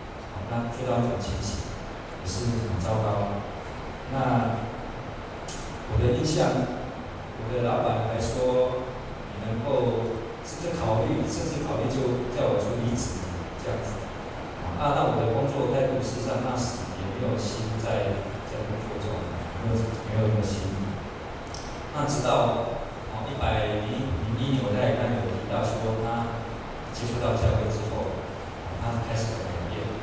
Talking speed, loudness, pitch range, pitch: 195 characters per minute, -28 LUFS, 105-120 Hz, 115 Hz